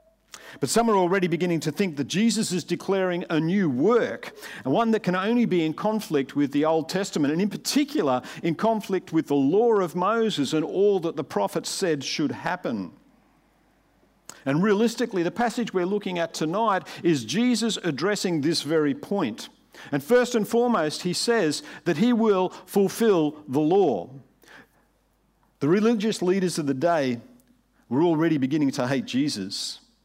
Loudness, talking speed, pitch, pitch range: -24 LUFS, 165 wpm, 190 Hz, 160-225 Hz